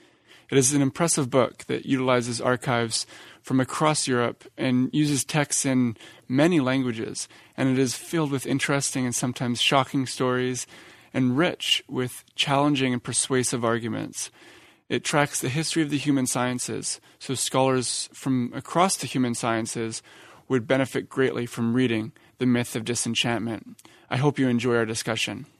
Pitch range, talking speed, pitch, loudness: 120-140 Hz, 150 wpm, 130 Hz, -25 LUFS